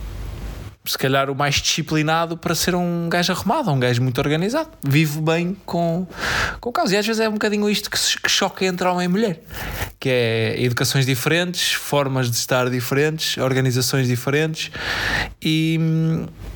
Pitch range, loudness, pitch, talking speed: 130-175 Hz, -20 LUFS, 155 Hz, 160 wpm